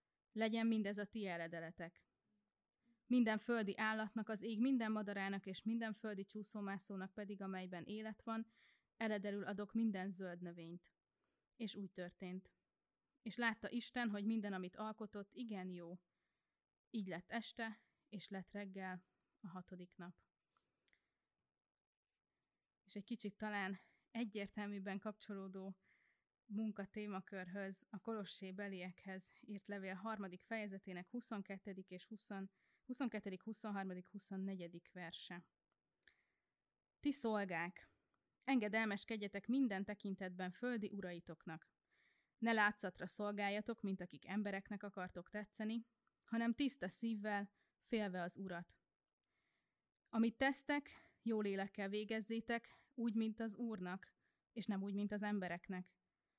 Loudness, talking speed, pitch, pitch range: -45 LUFS, 110 wpm, 205 Hz, 190-225 Hz